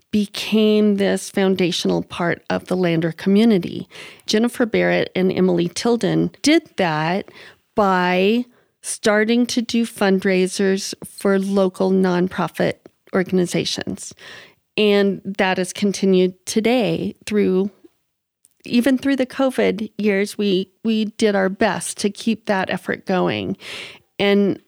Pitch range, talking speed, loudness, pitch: 185-220 Hz, 110 wpm, -19 LUFS, 200 Hz